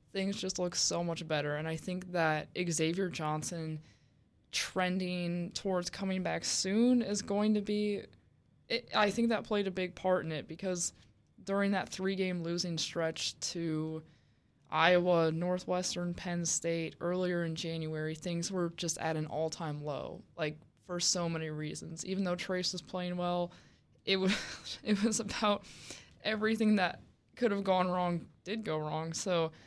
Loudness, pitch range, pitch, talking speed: -34 LUFS, 160-190 Hz, 175 Hz, 155 wpm